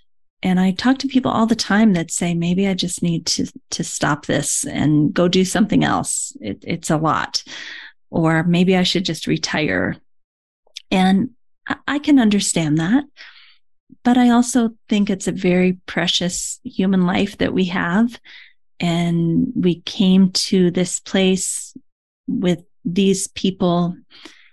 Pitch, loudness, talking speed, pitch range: 190 Hz, -18 LUFS, 150 wpm, 175-230 Hz